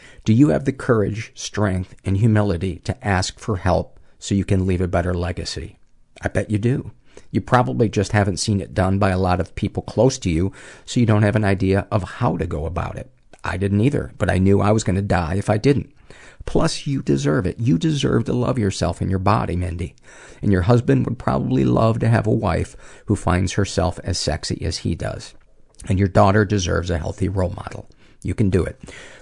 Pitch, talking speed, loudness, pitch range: 100 Hz, 220 wpm, -20 LUFS, 90-110 Hz